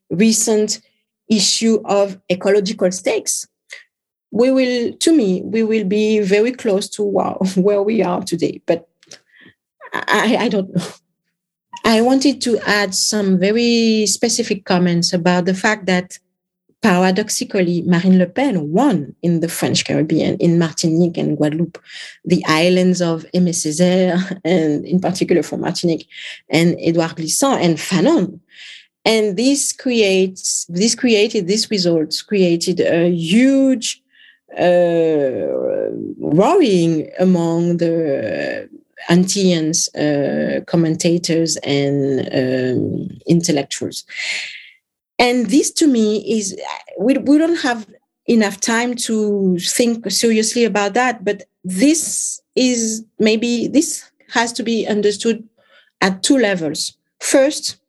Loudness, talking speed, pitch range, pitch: -16 LUFS, 115 wpm, 175-230 Hz, 200 Hz